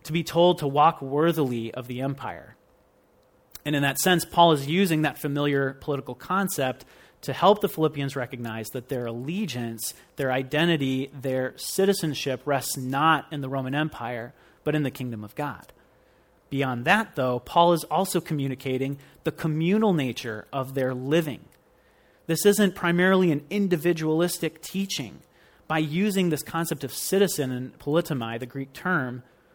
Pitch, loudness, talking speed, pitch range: 145 Hz, -25 LUFS, 150 wpm, 130-170 Hz